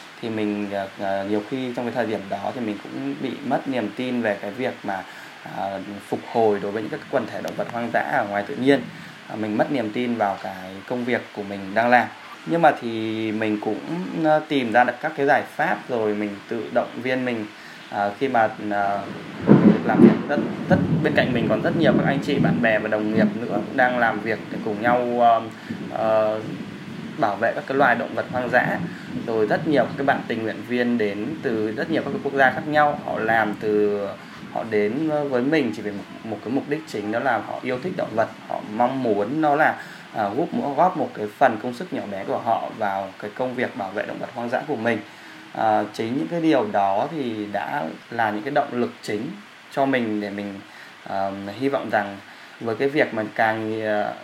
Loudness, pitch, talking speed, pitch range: -23 LUFS, 110 Hz, 220 wpm, 105-125 Hz